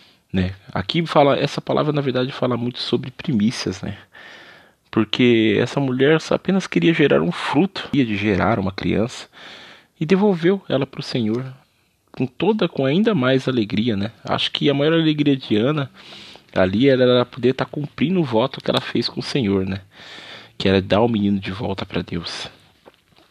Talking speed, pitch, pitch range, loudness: 180 wpm, 125 Hz, 105-145 Hz, -20 LUFS